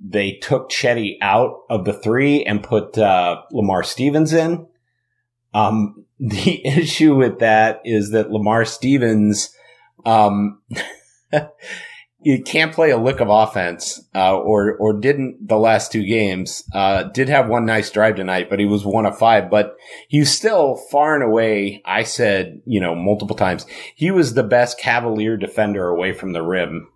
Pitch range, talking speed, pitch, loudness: 105-130 Hz, 160 wpm, 110 Hz, -17 LUFS